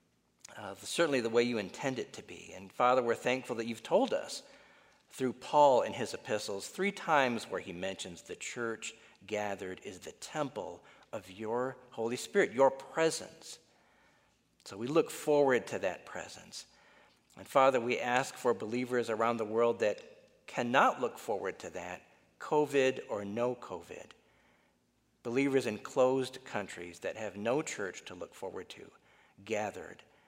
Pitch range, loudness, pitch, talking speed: 115-145 Hz, -33 LUFS, 125 Hz, 155 wpm